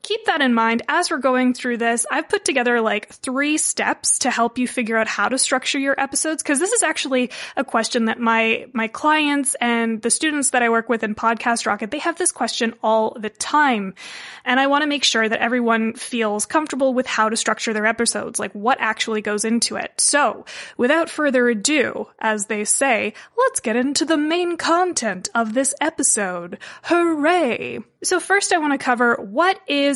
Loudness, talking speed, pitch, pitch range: -19 LUFS, 200 wpm, 250 Hz, 225-300 Hz